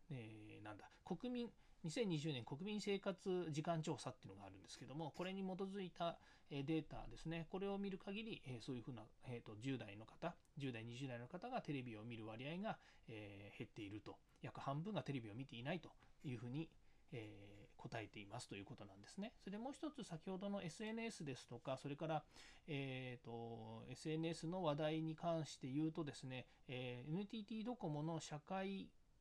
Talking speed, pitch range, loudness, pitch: 345 characters per minute, 125-180 Hz, -50 LUFS, 150 Hz